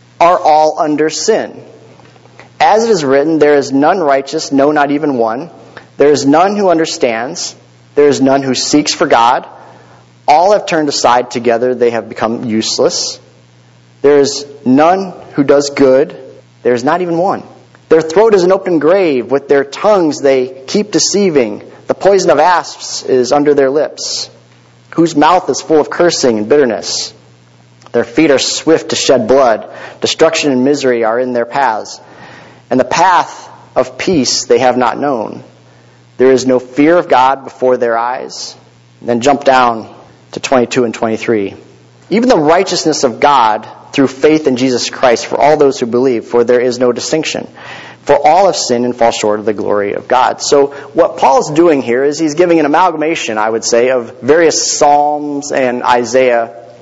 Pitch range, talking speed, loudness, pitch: 115-150 Hz, 175 wpm, -11 LUFS, 135 Hz